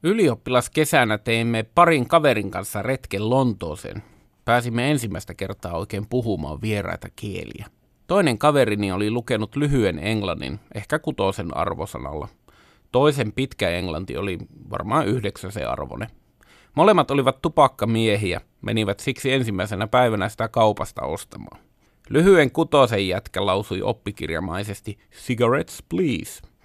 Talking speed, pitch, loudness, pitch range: 110 wpm, 110 Hz, -22 LUFS, 100-130 Hz